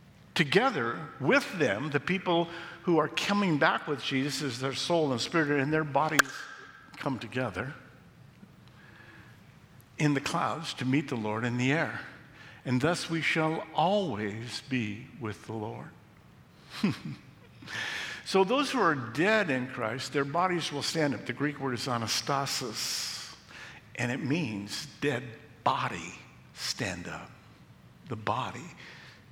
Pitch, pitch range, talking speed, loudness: 140 Hz, 120-155 Hz, 135 wpm, -30 LUFS